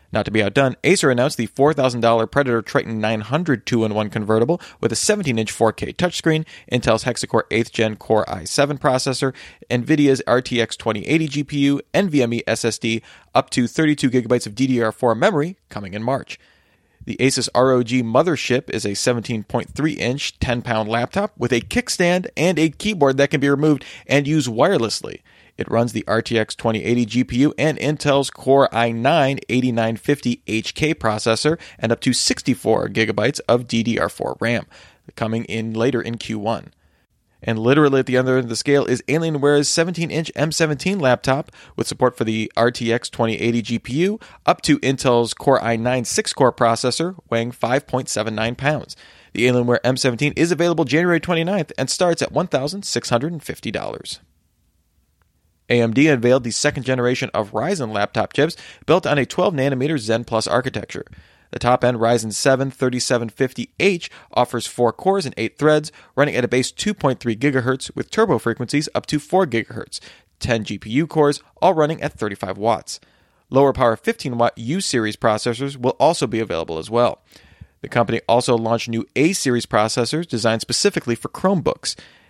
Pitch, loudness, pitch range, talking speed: 125 Hz, -19 LUFS, 115-145 Hz, 150 wpm